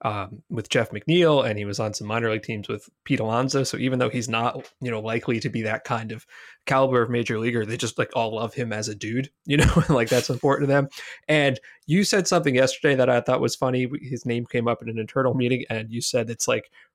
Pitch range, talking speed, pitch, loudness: 115-135 Hz, 250 wpm, 125 Hz, -24 LUFS